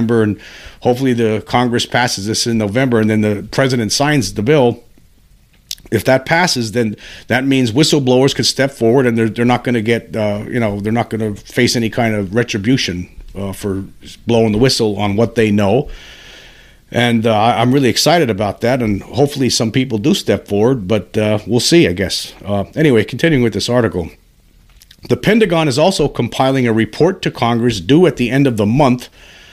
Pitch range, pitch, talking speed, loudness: 105-130 Hz, 115 Hz, 195 wpm, -14 LUFS